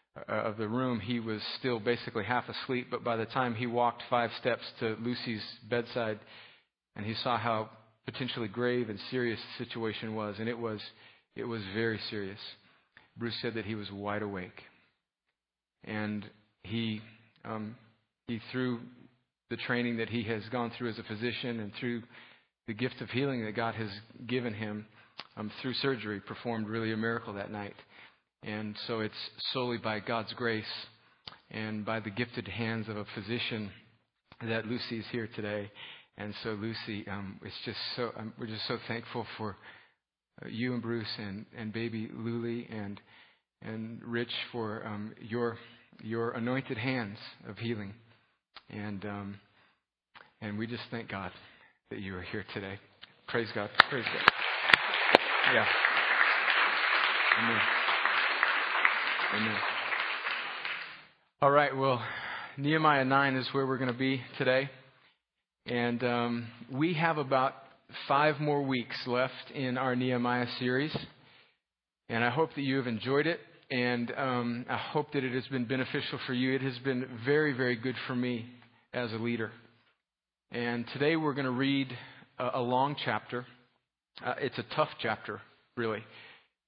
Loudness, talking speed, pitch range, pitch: -32 LUFS, 155 wpm, 110-125 Hz, 120 Hz